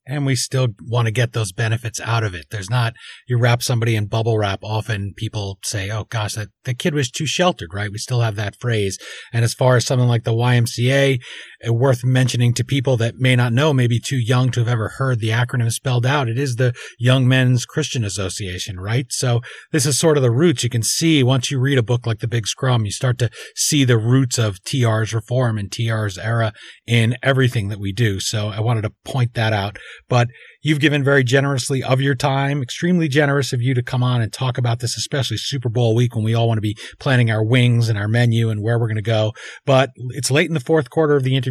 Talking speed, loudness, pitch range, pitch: 240 wpm, -19 LUFS, 115-130 Hz, 120 Hz